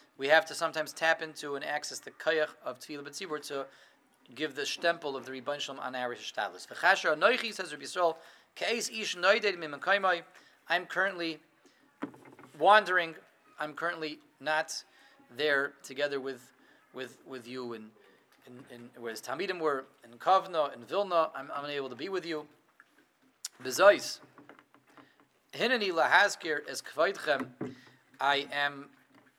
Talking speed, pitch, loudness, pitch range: 110 wpm, 150 Hz, -31 LUFS, 135-170 Hz